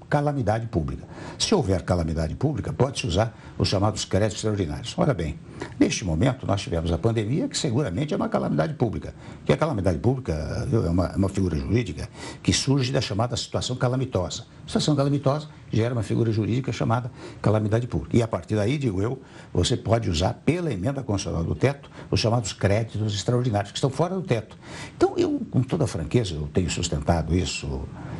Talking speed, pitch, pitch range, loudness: 175 wpm, 115 Hz, 95-130 Hz, -25 LUFS